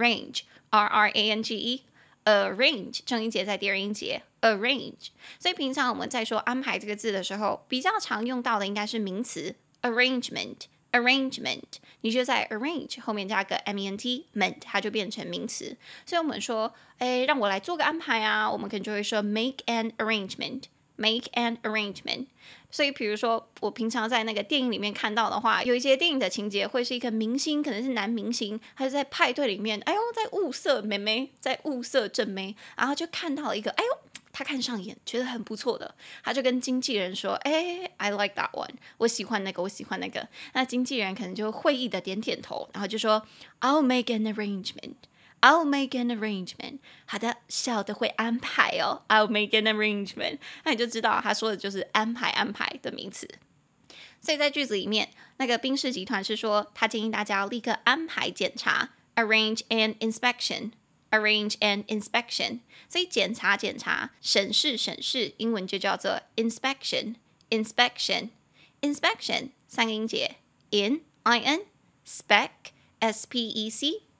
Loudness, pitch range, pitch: -27 LUFS, 215-260 Hz, 230 Hz